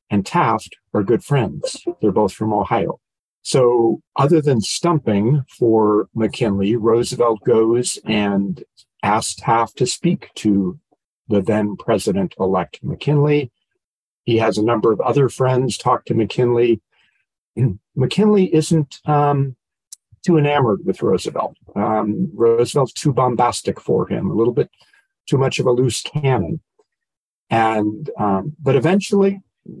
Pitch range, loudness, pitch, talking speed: 110-145 Hz, -18 LUFS, 125 Hz, 130 wpm